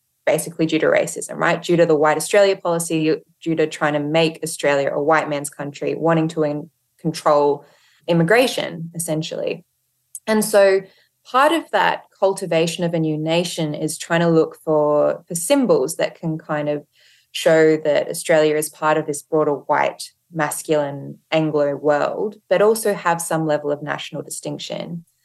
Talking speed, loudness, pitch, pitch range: 160 wpm, -19 LUFS, 160 Hz, 150-175 Hz